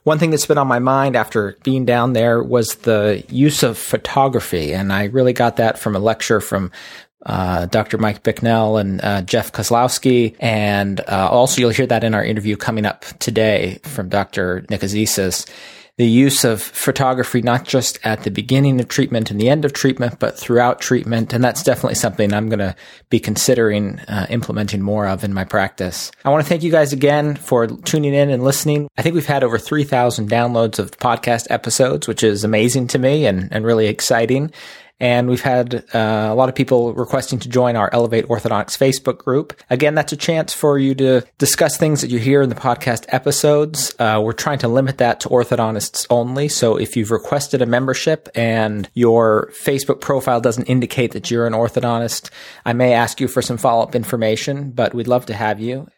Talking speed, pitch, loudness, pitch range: 200 wpm, 120 Hz, -17 LUFS, 110-135 Hz